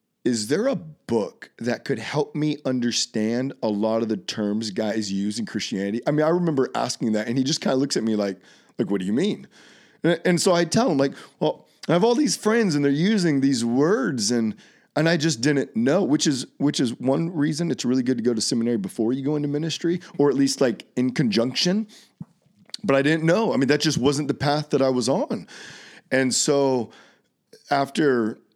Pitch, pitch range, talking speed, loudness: 140 Hz, 120-165 Hz, 220 wpm, -23 LUFS